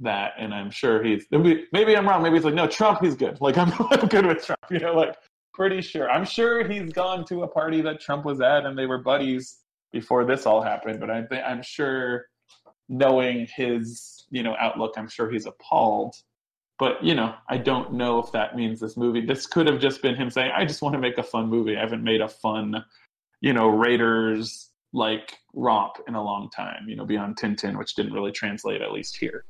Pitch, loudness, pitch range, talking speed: 130 Hz, -24 LUFS, 110-160 Hz, 220 wpm